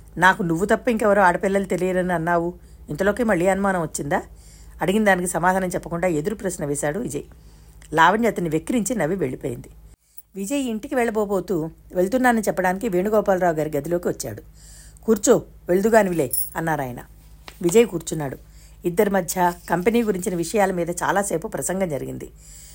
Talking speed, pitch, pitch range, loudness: 125 wpm, 185 Hz, 170-210 Hz, -21 LUFS